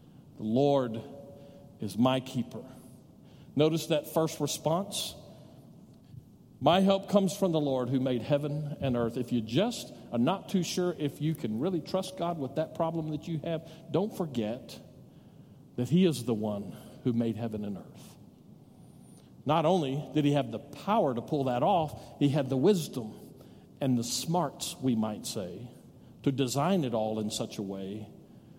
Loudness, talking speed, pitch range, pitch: -30 LUFS, 170 wpm, 120-165 Hz, 145 Hz